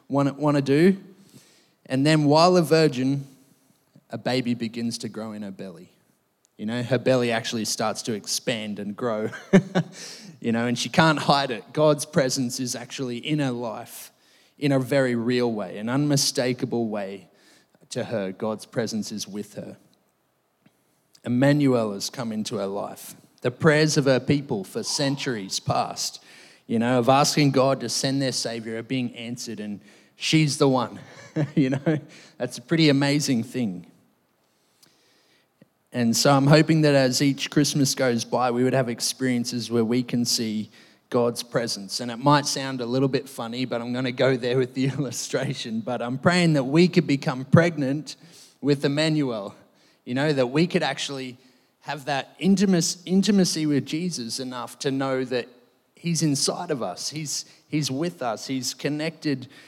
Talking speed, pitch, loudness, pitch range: 165 wpm, 135 Hz, -24 LUFS, 120-150 Hz